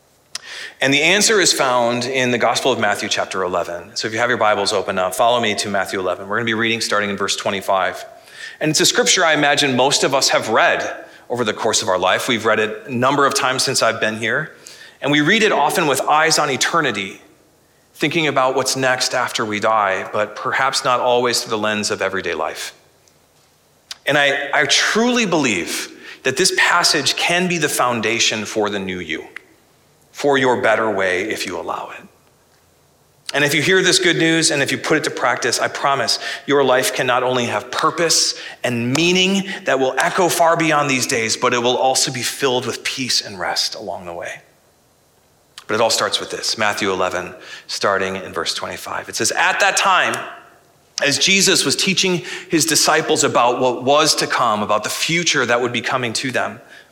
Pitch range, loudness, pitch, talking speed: 115-155 Hz, -17 LUFS, 130 Hz, 205 wpm